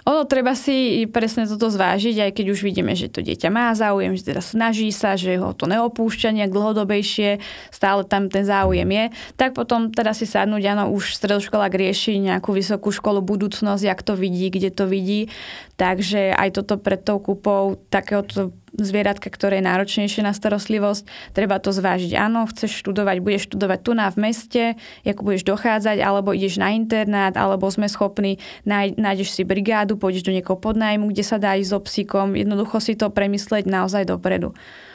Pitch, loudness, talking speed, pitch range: 205 Hz, -20 LUFS, 175 wpm, 195-215 Hz